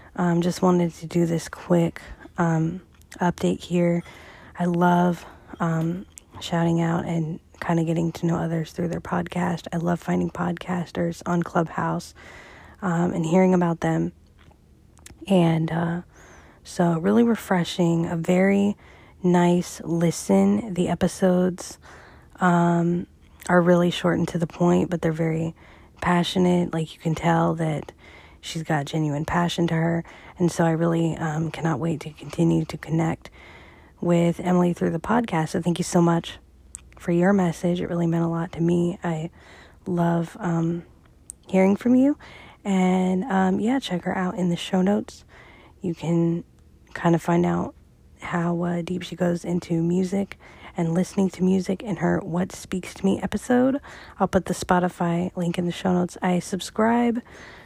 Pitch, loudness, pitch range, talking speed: 175 Hz, -23 LUFS, 165-180 Hz, 160 wpm